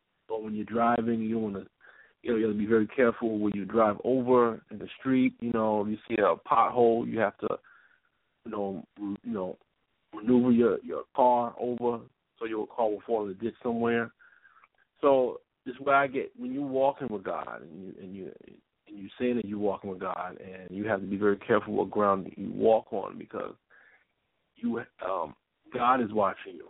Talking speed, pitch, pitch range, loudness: 205 wpm, 115 Hz, 105-120 Hz, -29 LUFS